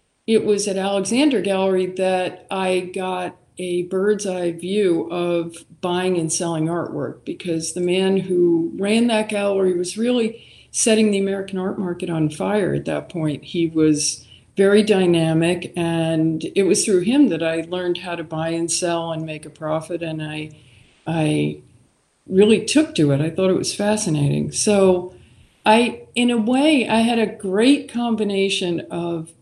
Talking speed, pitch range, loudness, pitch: 160 wpm, 165-205 Hz, -20 LUFS, 180 Hz